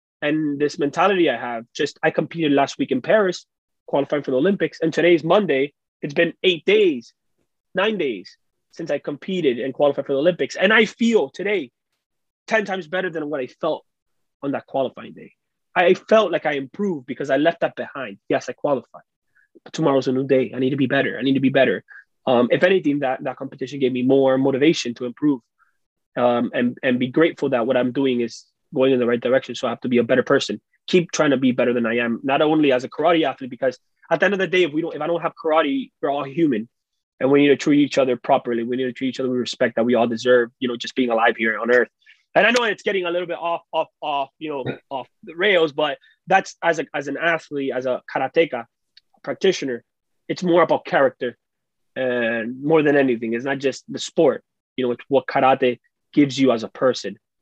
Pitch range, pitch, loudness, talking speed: 125-170 Hz, 140 Hz, -20 LUFS, 230 wpm